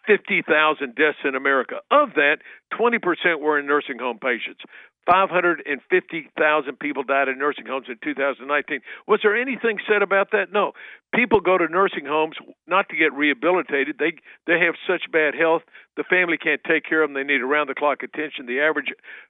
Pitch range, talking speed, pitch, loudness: 145-195 Hz, 175 wpm, 155 Hz, -21 LUFS